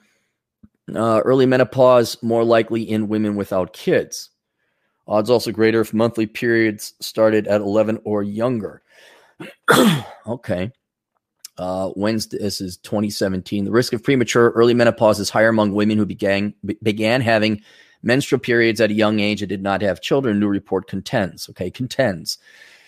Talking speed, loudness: 150 wpm, -19 LUFS